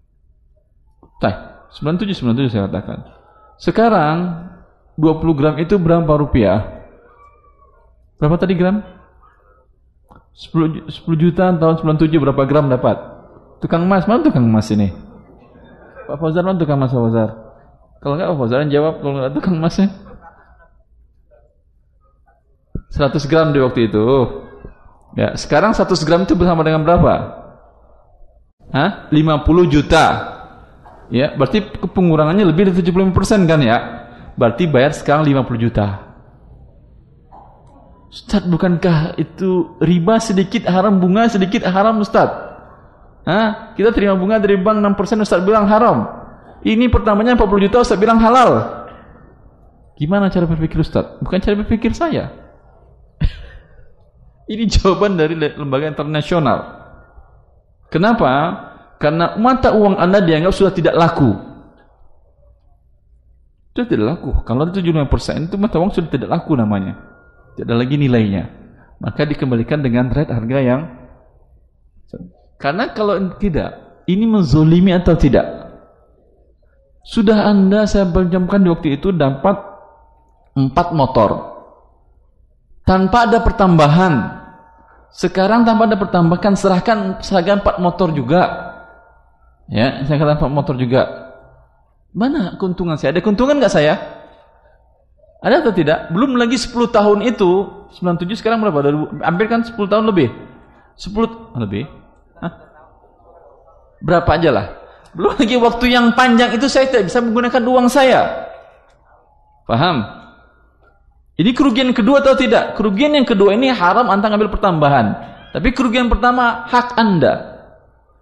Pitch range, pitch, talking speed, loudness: 140-210 Hz, 175 Hz, 125 wpm, -15 LUFS